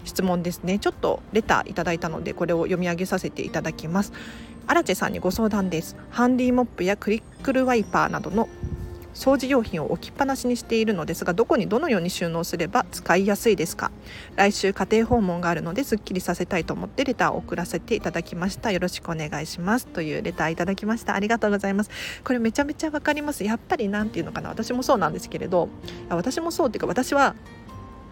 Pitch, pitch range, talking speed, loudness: 200 Hz, 175-235 Hz, 480 characters per minute, -24 LUFS